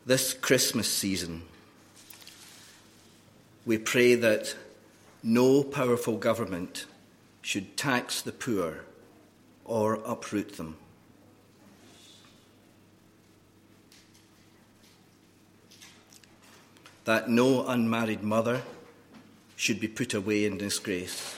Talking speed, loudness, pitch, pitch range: 75 wpm, -28 LUFS, 110 Hz, 105-115 Hz